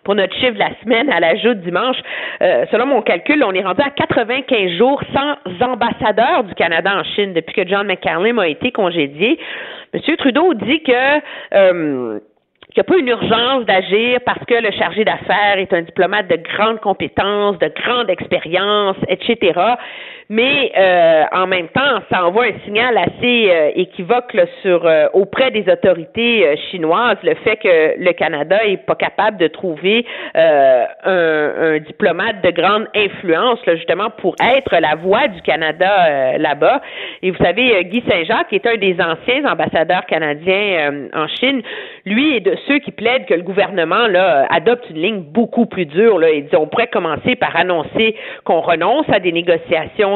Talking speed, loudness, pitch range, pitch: 180 wpm, -15 LUFS, 180-250 Hz, 205 Hz